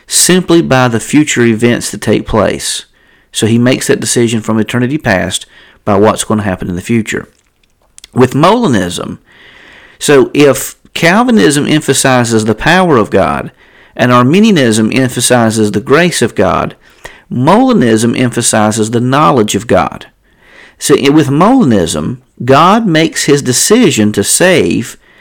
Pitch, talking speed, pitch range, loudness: 125 Hz, 135 wpm, 110-145 Hz, -9 LUFS